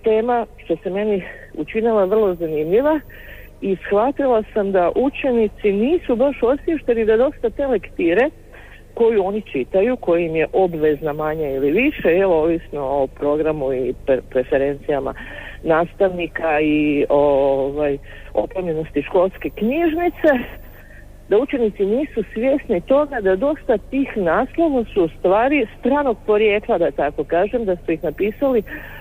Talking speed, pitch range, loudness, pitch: 130 wpm, 155-245 Hz, -19 LUFS, 200 Hz